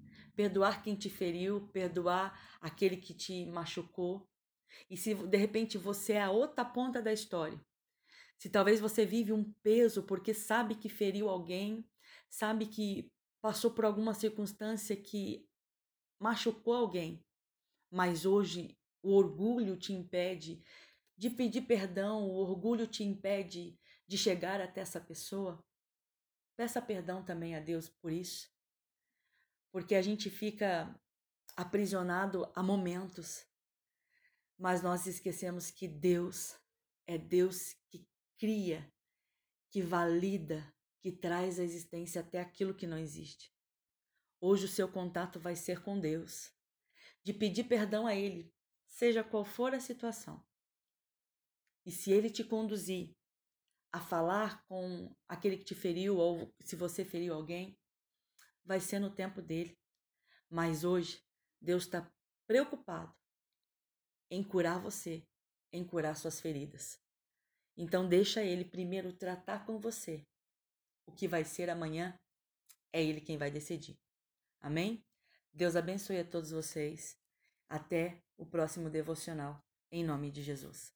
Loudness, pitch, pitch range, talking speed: -37 LUFS, 185 Hz, 170-210 Hz, 130 wpm